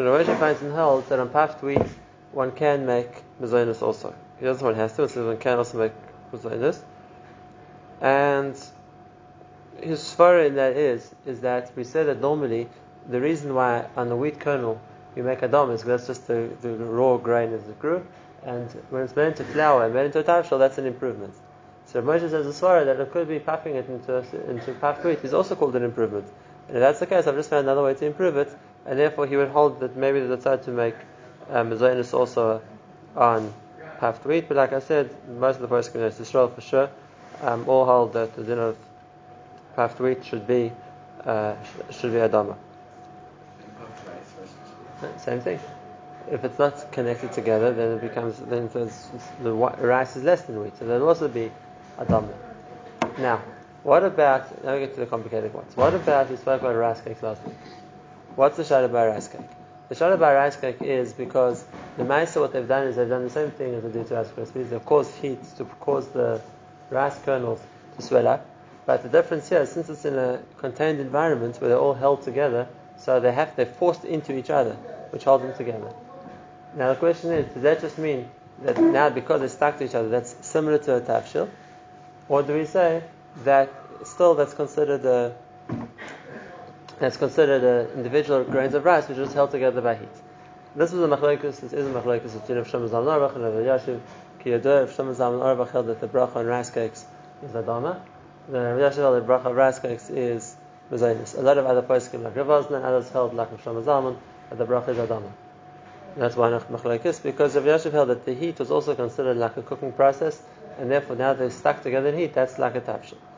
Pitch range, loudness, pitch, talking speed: 120-145 Hz, -23 LUFS, 130 Hz, 210 wpm